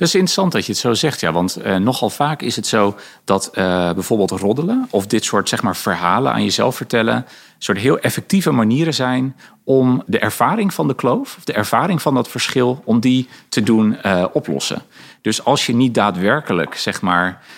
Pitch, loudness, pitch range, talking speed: 125 Hz, -17 LUFS, 105-150 Hz, 200 wpm